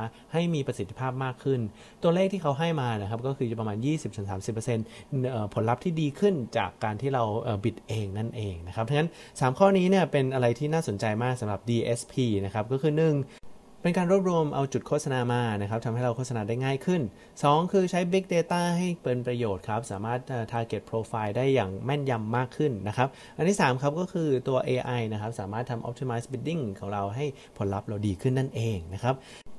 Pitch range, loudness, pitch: 110-150 Hz, -28 LUFS, 125 Hz